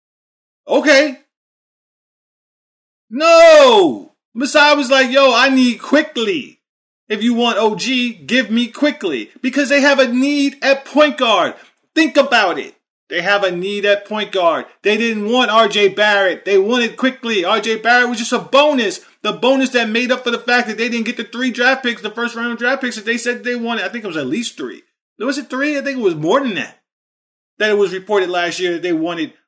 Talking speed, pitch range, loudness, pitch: 205 wpm, 215-275 Hz, -15 LUFS, 240 Hz